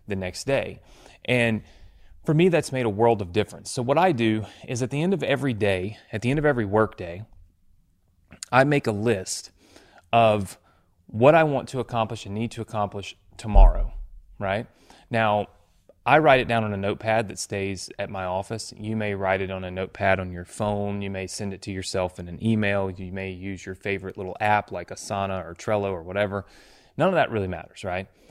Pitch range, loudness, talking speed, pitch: 95-115 Hz, -25 LUFS, 205 wpm, 100 Hz